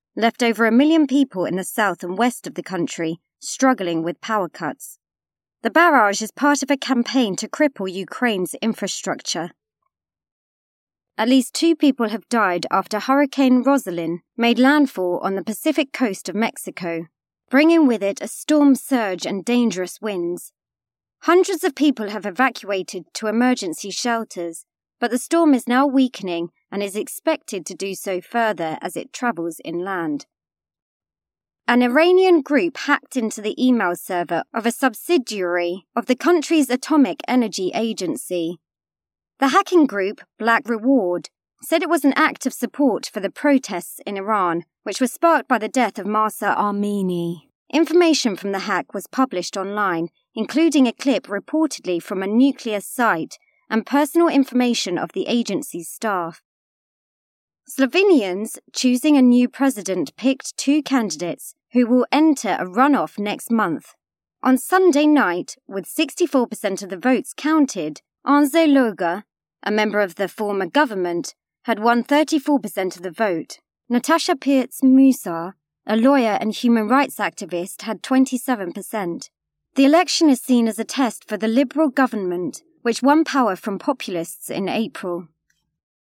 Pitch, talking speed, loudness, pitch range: 230 Hz, 145 wpm, -20 LUFS, 195-275 Hz